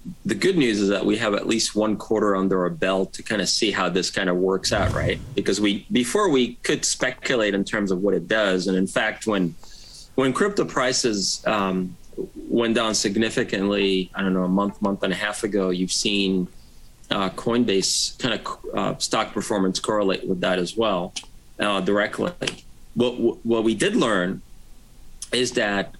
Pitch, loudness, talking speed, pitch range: 100 Hz, -22 LUFS, 185 wpm, 95-110 Hz